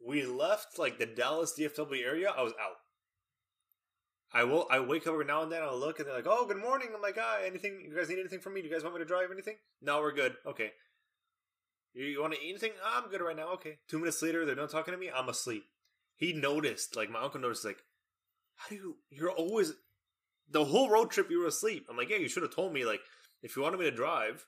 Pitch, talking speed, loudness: 195 Hz, 255 wpm, -34 LUFS